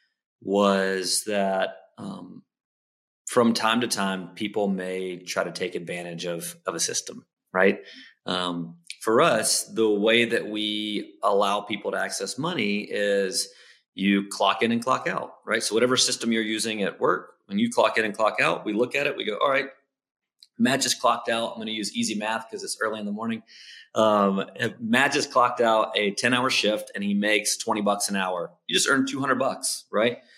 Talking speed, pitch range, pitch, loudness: 195 wpm, 95-115 Hz, 105 Hz, -24 LUFS